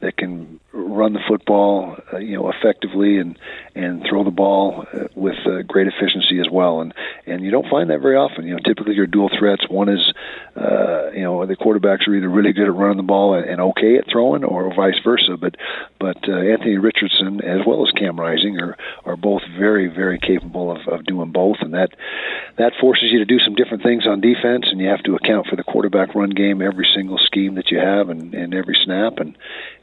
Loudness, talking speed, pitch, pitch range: -17 LUFS, 225 wpm, 100 Hz, 95-105 Hz